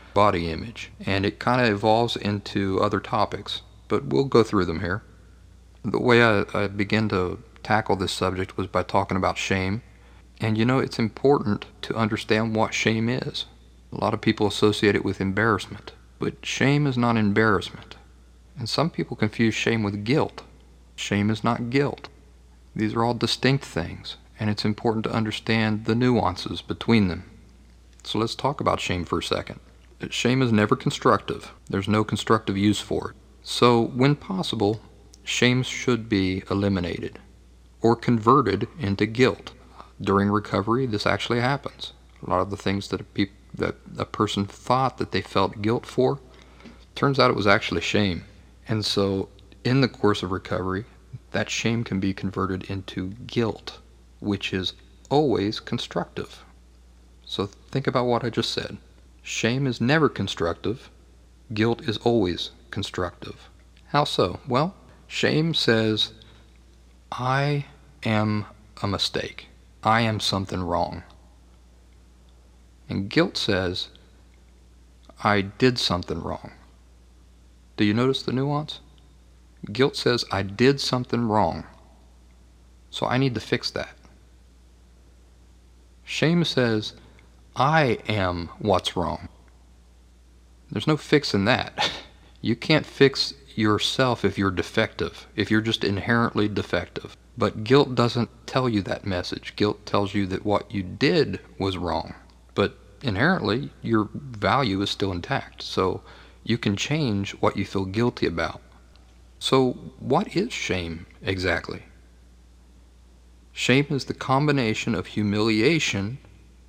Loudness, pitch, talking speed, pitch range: -24 LUFS, 100 Hz, 140 wpm, 70-115 Hz